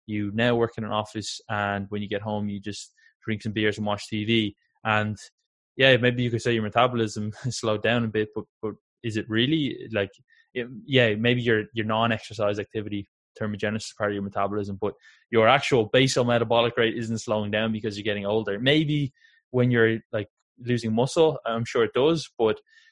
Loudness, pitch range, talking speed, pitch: -25 LUFS, 105-120 Hz, 195 wpm, 110 Hz